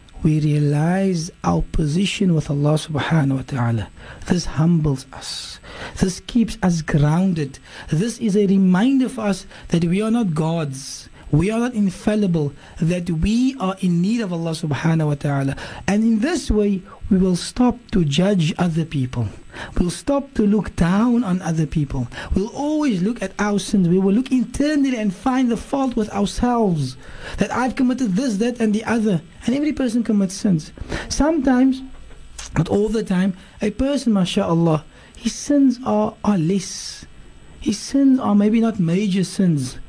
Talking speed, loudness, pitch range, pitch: 165 wpm, -20 LUFS, 160-225 Hz, 195 Hz